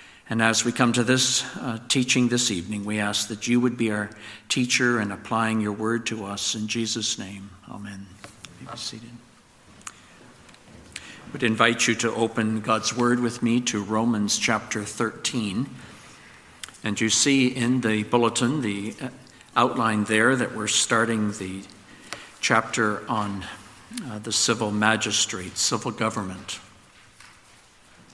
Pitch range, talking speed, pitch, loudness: 105-120 Hz, 140 wpm, 110 Hz, -23 LUFS